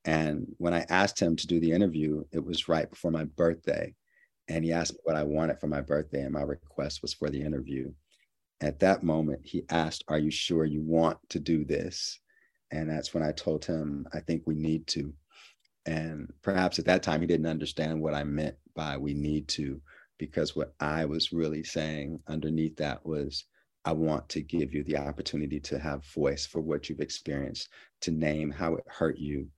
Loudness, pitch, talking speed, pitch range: -31 LUFS, 80 Hz, 200 wpm, 75-80 Hz